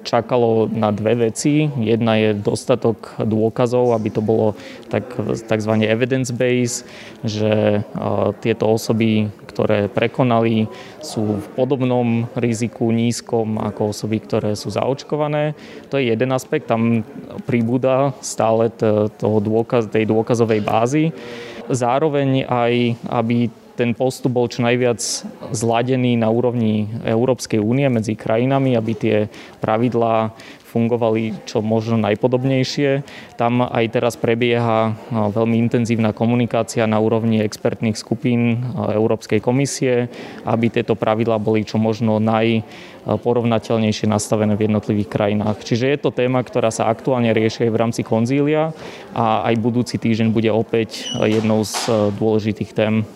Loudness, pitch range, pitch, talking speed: -19 LUFS, 110-125 Hz, 115 Hz, 120 wpm